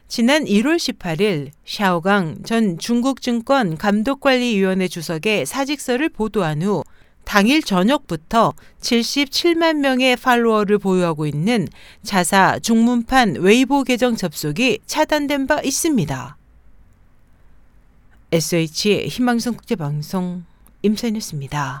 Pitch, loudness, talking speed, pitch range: 215 Hz, -18 LUFS, 235 characters per minute, 175-255 Hz